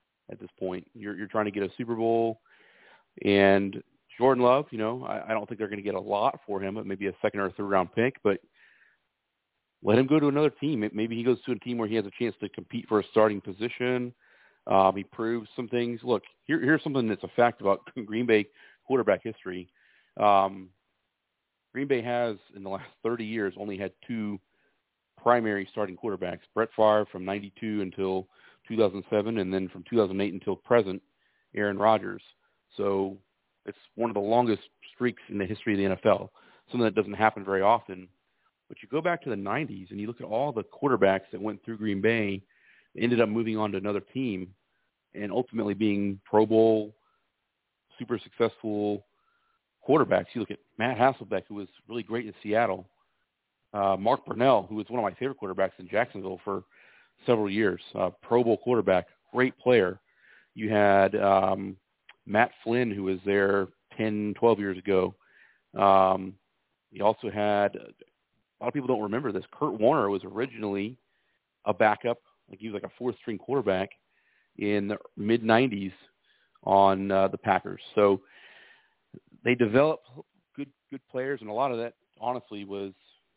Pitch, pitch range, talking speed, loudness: 105 Hz, 100-115 Hz, 180 wpm, -27 LUFS